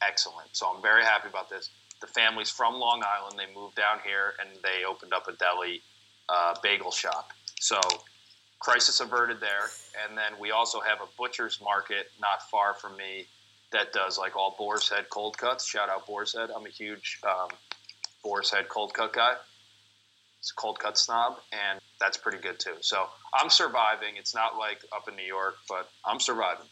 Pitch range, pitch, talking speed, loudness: 100-115 Hz, 105 Hz, 190 wpm, -28 LUFS